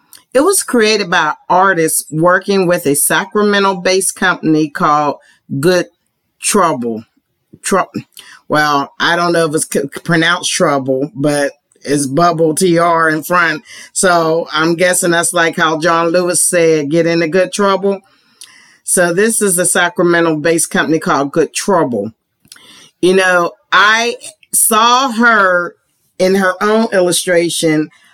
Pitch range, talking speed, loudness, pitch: 160-185 Hz, 130 wpm, -12 LUFS, 175 Hz